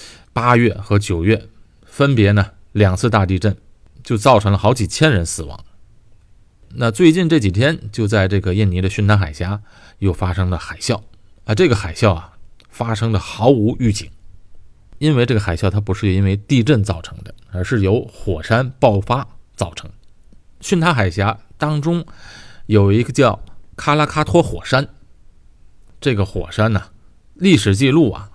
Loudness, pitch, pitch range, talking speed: -17 LUFS, 105 Hz, 95-120 Hz, 235 characters per minute